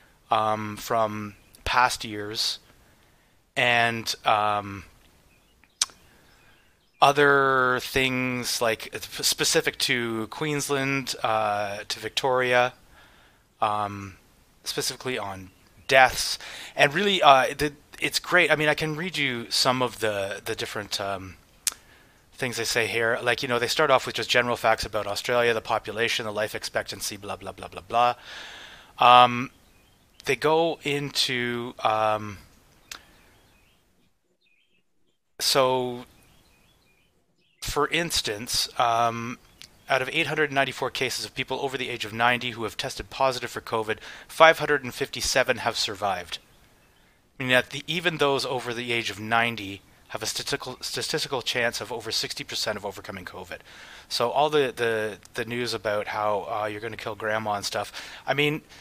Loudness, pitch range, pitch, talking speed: -24 LUFS, 105-130 Hz, 120 Hz, 135 wpm